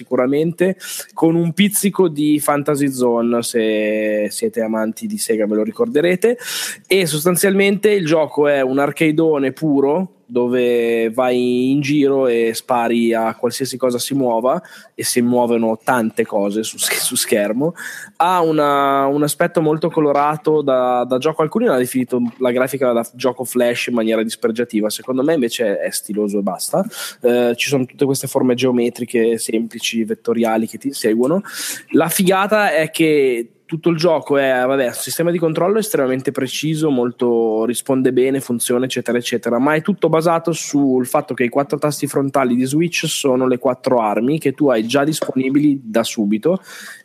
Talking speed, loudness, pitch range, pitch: 160 wpm, -17 LUFS, 120-155 Hz, 130 Hz